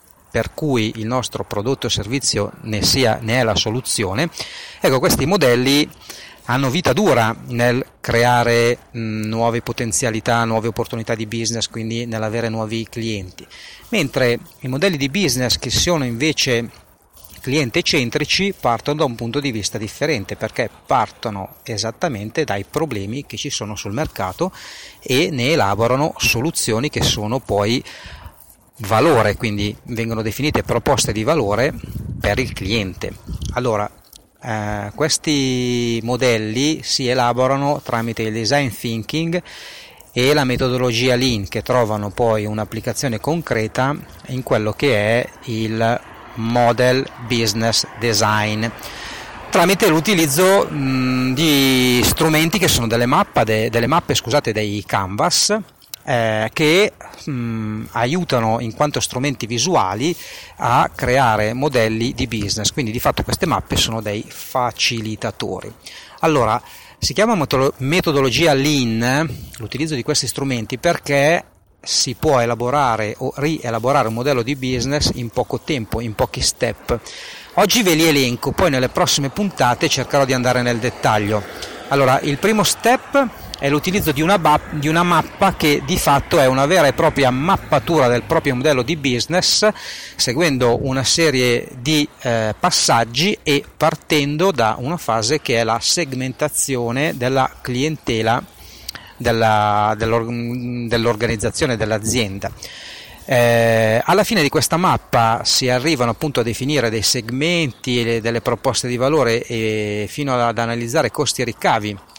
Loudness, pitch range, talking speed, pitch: -18 LUFS, 115-145 Hz, 130 wpm, 125 Hz